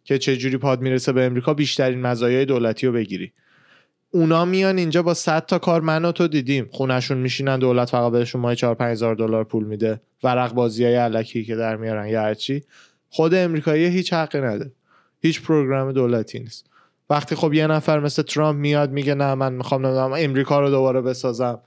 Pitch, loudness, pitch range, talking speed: 135 Hz, -20 LUFS, 120-155 Hz, 185 wpm